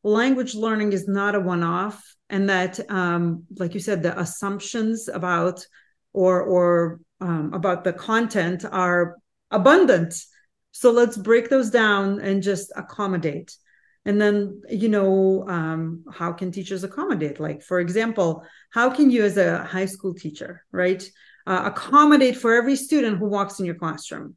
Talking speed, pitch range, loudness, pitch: 155 wpm, 180-220 Hz, -21 LUFS, 195 Hz